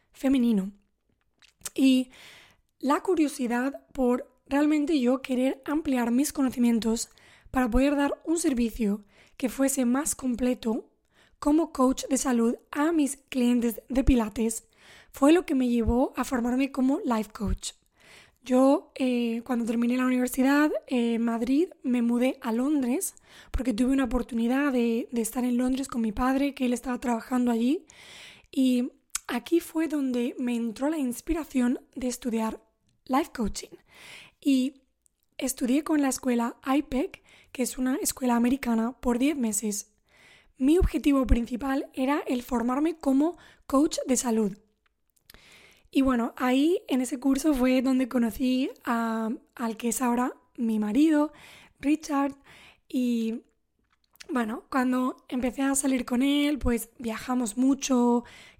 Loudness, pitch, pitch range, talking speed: -27 LUFS, 260 Hz, 240-280 Hz, 135 wpm